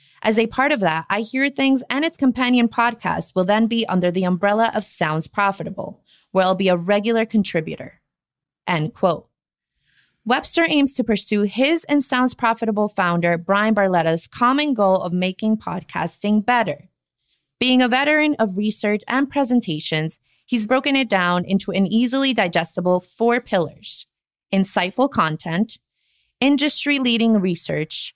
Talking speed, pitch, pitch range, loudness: 145 wpm, 215 Hz, 185-250 Hz, -19 LUFS